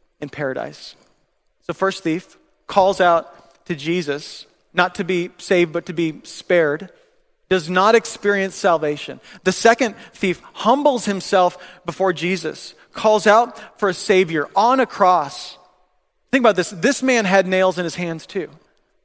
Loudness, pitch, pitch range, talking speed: -18 LUFS, 185 Hz, 175-215 Hz, 150 wpm